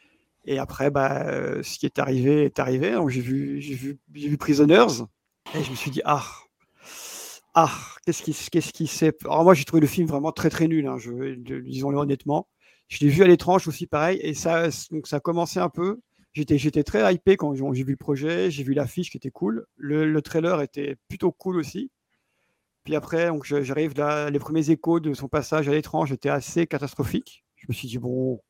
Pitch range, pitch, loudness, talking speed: 140-160 Hz, 150 Hz, -24 LUFS, 215 wpm